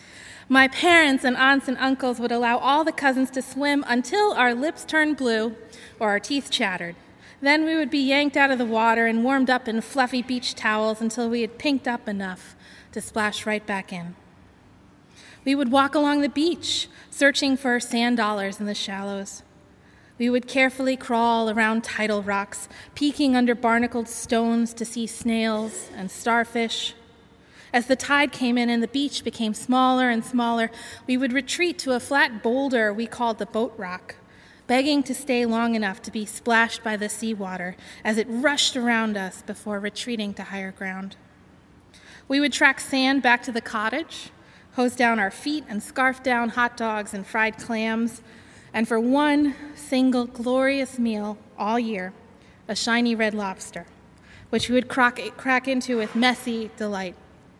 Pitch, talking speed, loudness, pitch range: 235 Hz, 170 wpm, -23 LUFS, 220-265 Hz